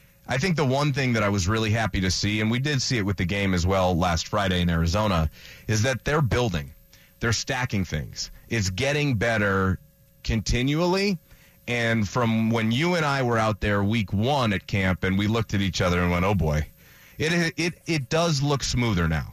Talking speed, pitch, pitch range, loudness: 210 wpm, 110 Hz, 95-130 Hz, -24 LUFS